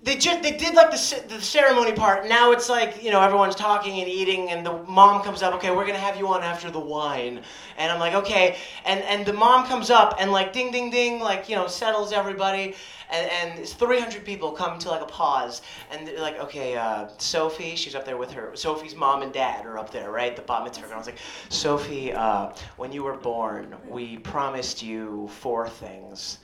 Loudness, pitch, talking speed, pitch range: -23 LUFS, 185 Hz, 225 wpm, 135-210 Hz